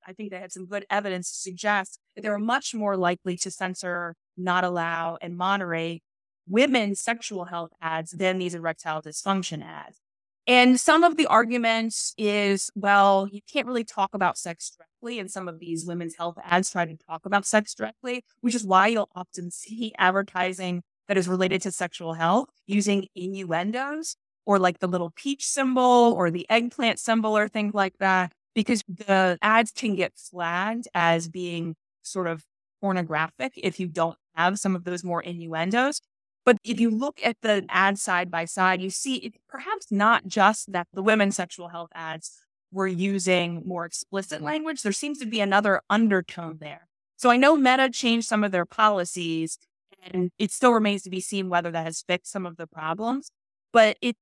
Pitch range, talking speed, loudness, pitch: 175-220 Hz, 185 wpm, -24 LUFS, 190 Hz